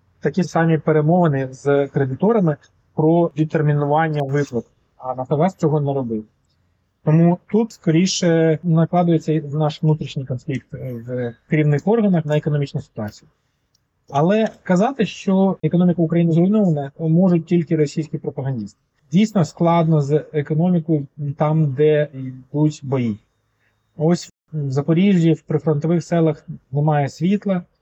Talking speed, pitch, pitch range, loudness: 110 wpm, 155 Hz, 140-170 Hz, -19 LUFS